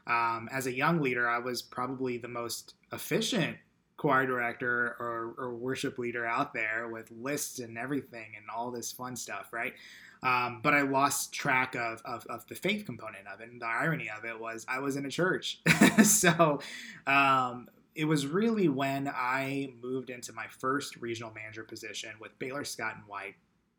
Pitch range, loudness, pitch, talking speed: 115-140 Hz, -30 LUFS, 125 Hz, 180 wpm